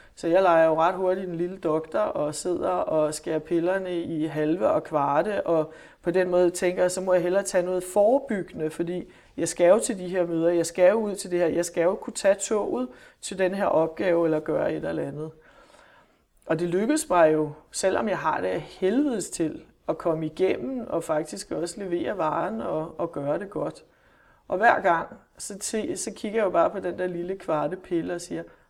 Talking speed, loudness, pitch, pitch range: 215 wpm, -25 LUFS, 180 Hz, 165-190 Hz